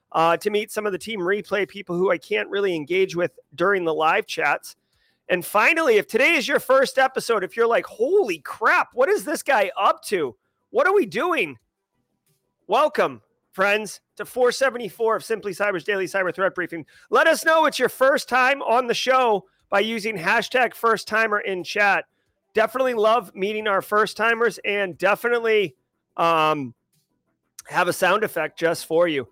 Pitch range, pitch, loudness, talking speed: 190-250 Hz, 210 Hz, -21 LUFS, 175 wpm